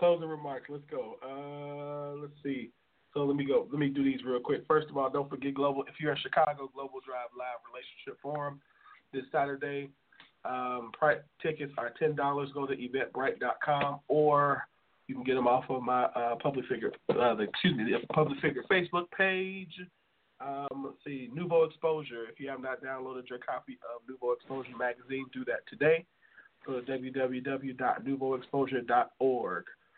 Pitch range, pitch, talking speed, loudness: 130-145 Hz, 140 Hz, 165 wpm, -33 LUFS